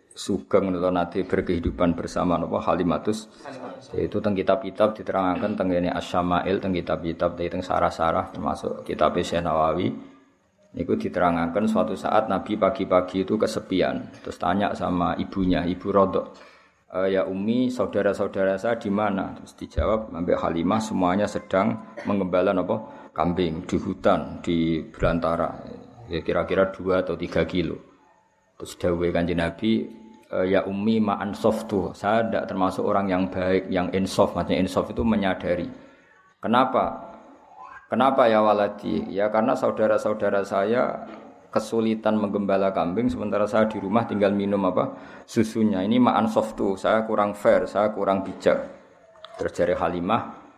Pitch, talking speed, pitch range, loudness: 95 Hz, 125 wpm, 90-105 Hz, -24 LUFS